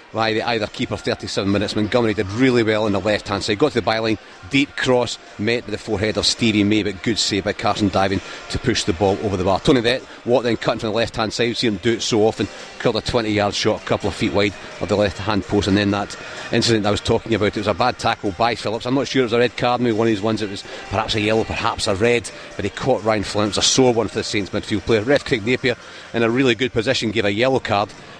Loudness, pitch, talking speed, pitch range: -19 LUFS, 110 Hz, 290 wpm, 105-115 Hz